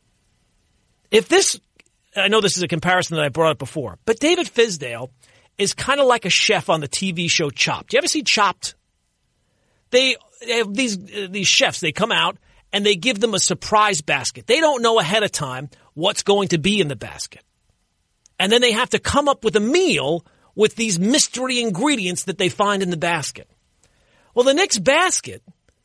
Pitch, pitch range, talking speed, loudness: 200 Hz, 165-240 Hz, 195 wpm, -18 LUFS